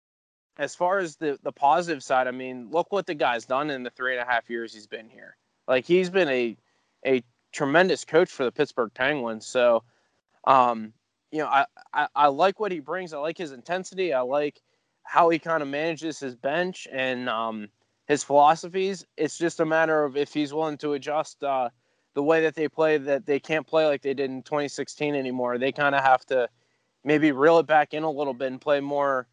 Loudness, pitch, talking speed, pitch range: -25 LUFS, 145 Hz, 215 wpm, 130-160 Hz